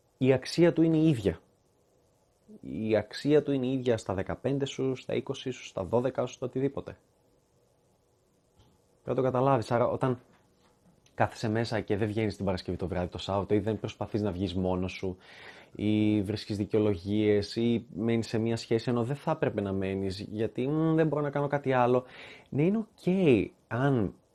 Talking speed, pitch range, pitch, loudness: 180 wpm, 105-135 Hz, 115 Hz, -29 LUFS